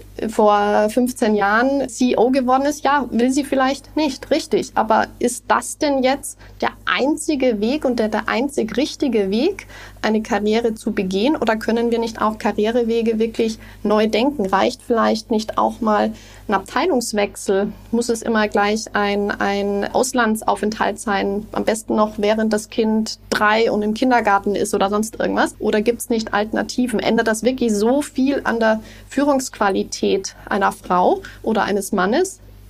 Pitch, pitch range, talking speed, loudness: 225 Hz, 210-255 Hz, 160 wpm, -19 LUFS